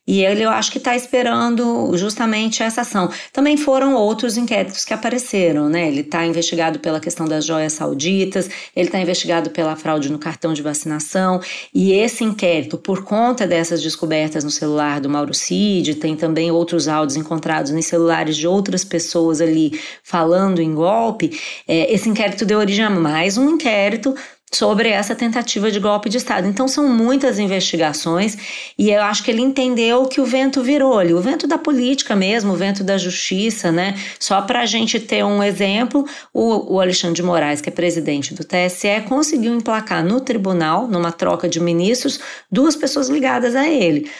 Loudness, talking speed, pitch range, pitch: -17 LUFS, 175 wpm, 165-235 Hz, 195 Hz